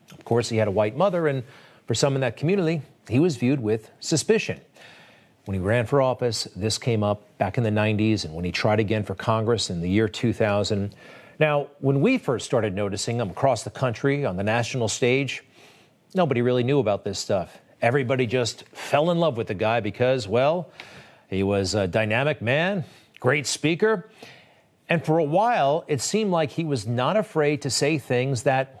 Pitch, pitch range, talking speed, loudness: 125 Hz, 110-145 Hz, 195 wpm, -24 LUFS